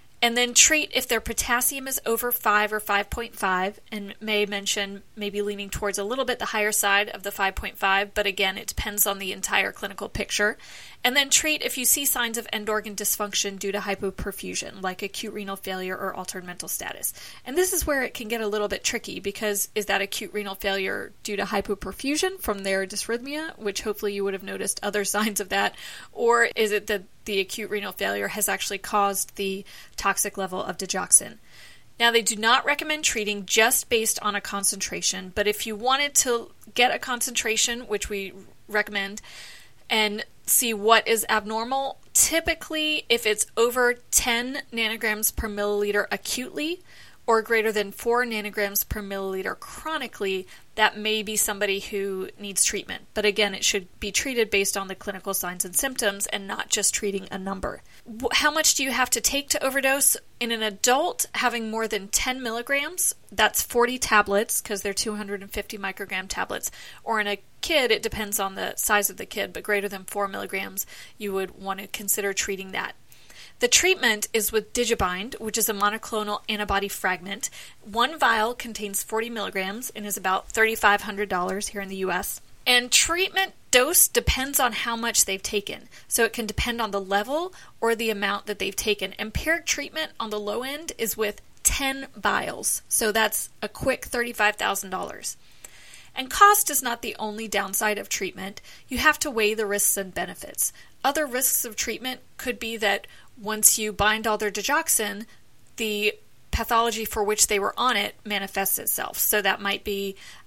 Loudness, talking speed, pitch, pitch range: -24 LUFS, 180 wpm, 215 Hz, 200-240 Hz